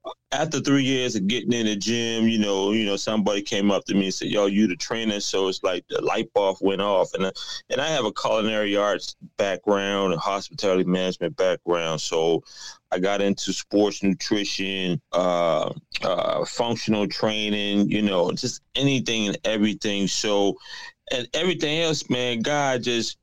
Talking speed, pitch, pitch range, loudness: 175 wpm, 105 Hz, 95-115 Hz, -23 LUFS